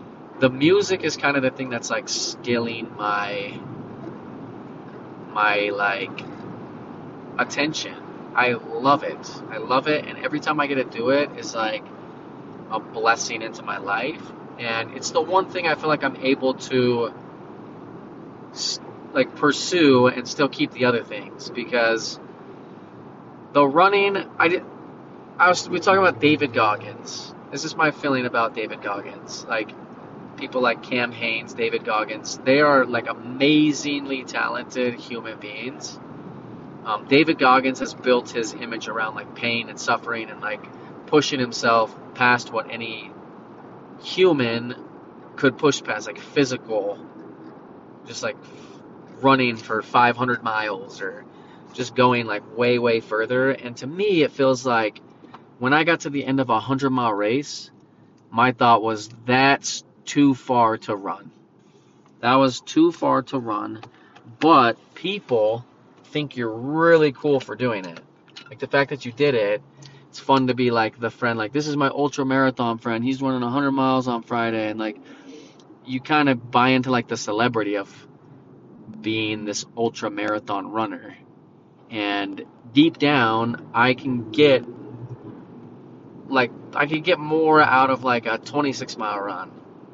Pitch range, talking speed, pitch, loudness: 115-145 Hz, 150 wpm, 125 Hz, -22 LUFS